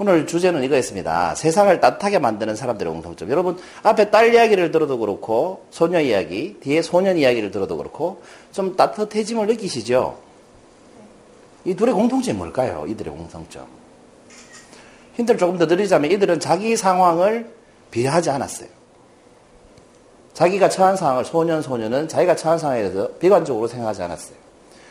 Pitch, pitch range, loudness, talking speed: 180 Hz, 155-210 Hz, -19 LUFS, 365 characters per minute